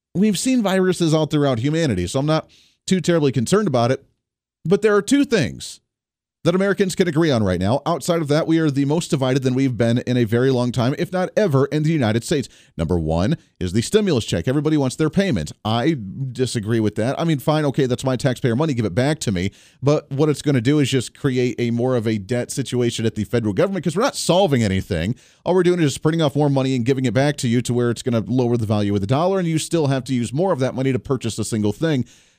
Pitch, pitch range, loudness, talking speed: 135 Hz, 120-160 Hz, -20 LUFS, 260 wpm